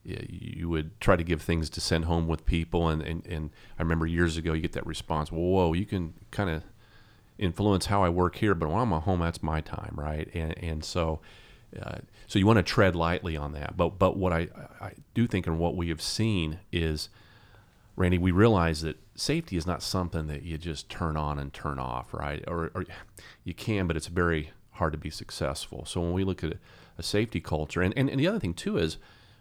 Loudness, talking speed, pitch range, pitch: -29 LUFS, 225 wpm, 80-100 Hz, 85 Hz